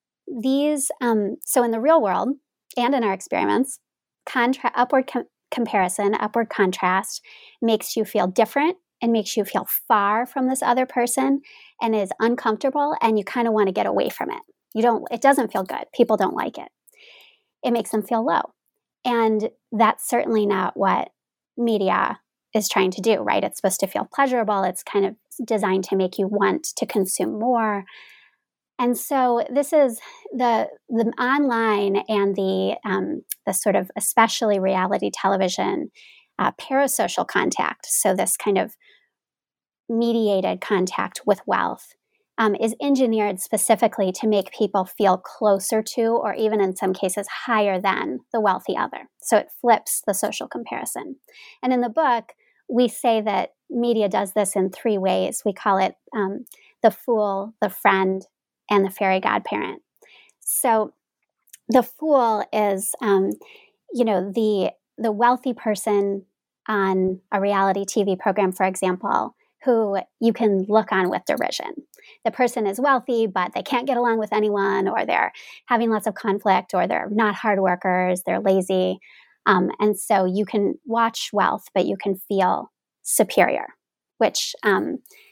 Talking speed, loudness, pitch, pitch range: 160 wpm, -22 LUFS, 220 Hz, 200-250 Hz